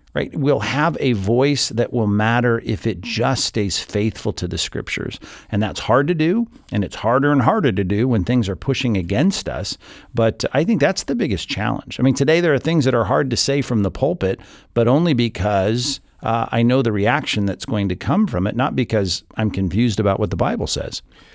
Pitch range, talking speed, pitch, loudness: 105-135 Hz, 220 wpm, 115 Hz, -19 LUFS